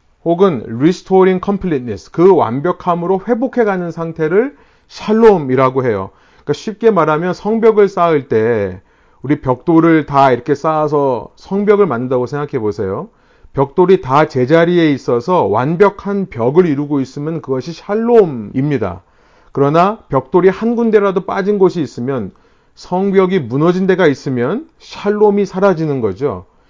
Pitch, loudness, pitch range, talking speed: 170 Hz, -14 LUFS, 140-200 Hz, 340 characters per minute